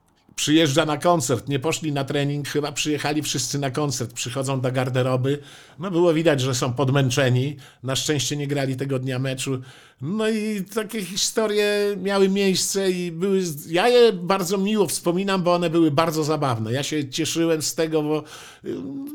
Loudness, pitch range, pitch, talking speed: -22 LUFS, 140-185 Hz, 155 Hz, 165 wpm